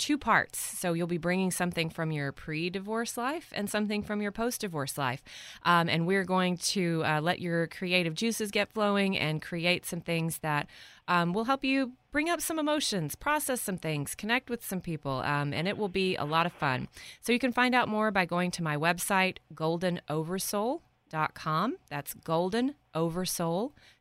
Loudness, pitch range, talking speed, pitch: -30 LUFS, 165-220 Hz, 185 wpm, 180 Hz